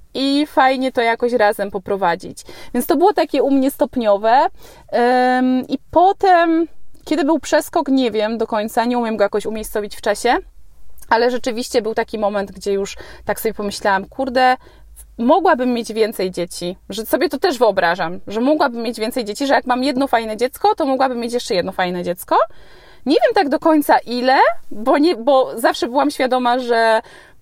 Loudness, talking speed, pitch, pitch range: -17 LUFS, 175 wpm, 245 Hz, 215-290 Hz